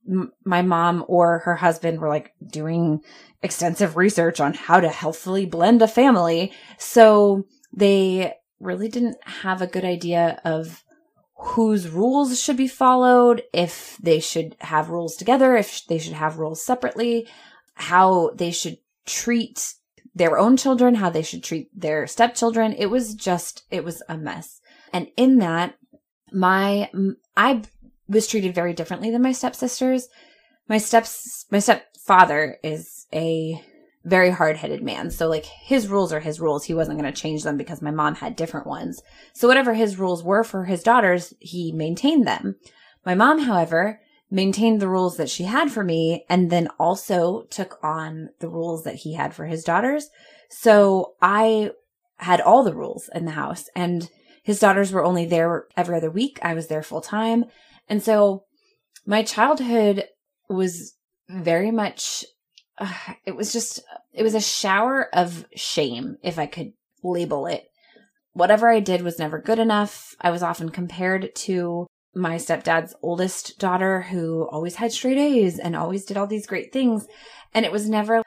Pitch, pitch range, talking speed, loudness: 190 Hz, 170-230 Hz, 165 wpm, -21 LUFS